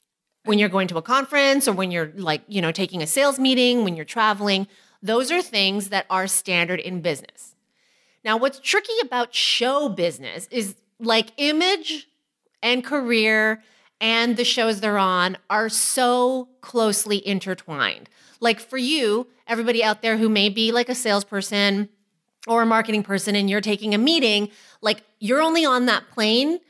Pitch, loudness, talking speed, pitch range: 220 Hz, -21 LUFS, 165 wpm, 200-250 Hz